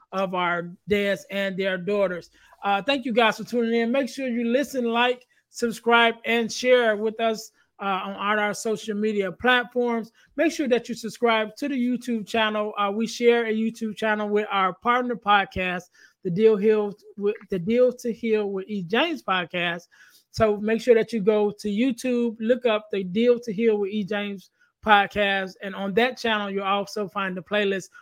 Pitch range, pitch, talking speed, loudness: 200-235 Hz, 215 Hz, 190 wpm, -24 LUFS